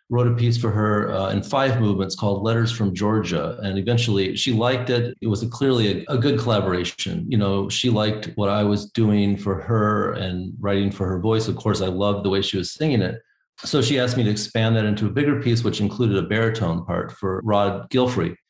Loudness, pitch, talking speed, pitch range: -22 LUFS, 105 Hz, 225 wpm, 100-120 Hz